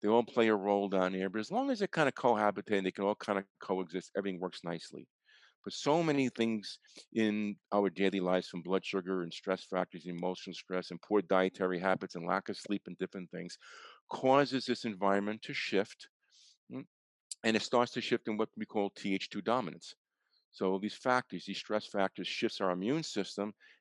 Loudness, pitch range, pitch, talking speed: -34 LUFS, 95-110 Hz, 100 Hz, 195 wpm